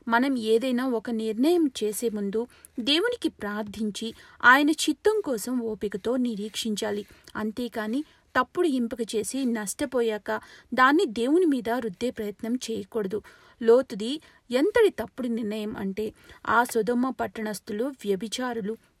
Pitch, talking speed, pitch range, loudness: 235 Hz, 105 wpm, 220-255 Hz, -26 LUFS